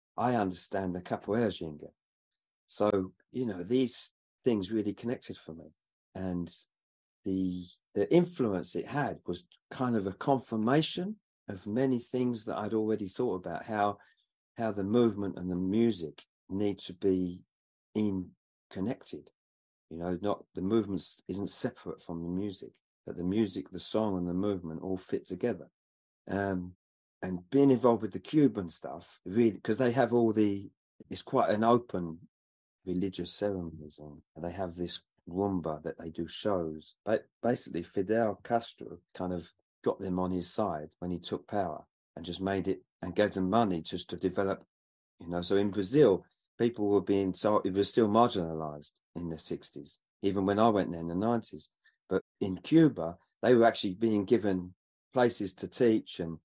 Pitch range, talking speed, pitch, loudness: 90-110 Hz, 165 wpm, 100 Hz, -32 LUFS